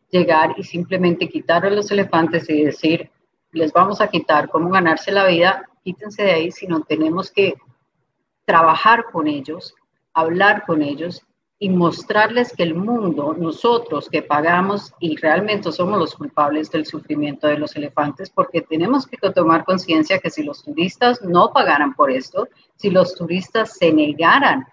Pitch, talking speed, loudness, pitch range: 170 Hz, 160 wpm, -17 LUFS, 160-195 Hz